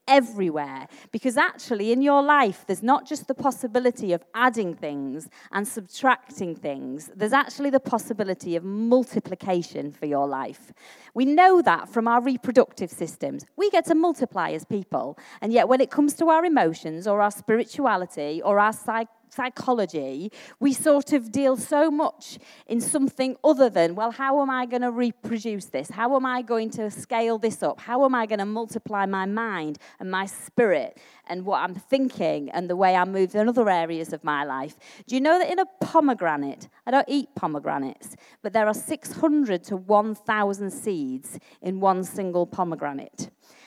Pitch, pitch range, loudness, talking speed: 225 Hz, 185-265 Hz, -24 LUFS, 175 wpm